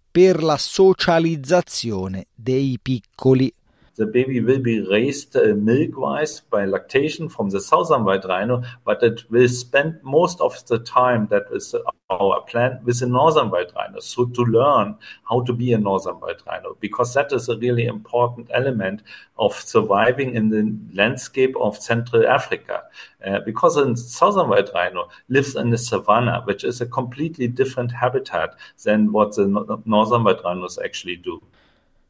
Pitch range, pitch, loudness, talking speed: 115-135 Hz, 125 Hz, -20 LUFS, 160 wpm